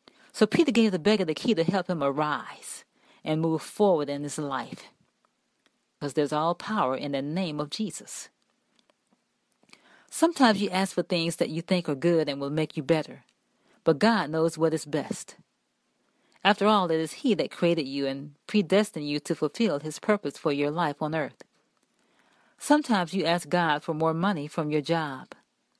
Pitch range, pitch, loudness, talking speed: 150-200 Hz, 165 Hz, -27 LUFS, 180 wpm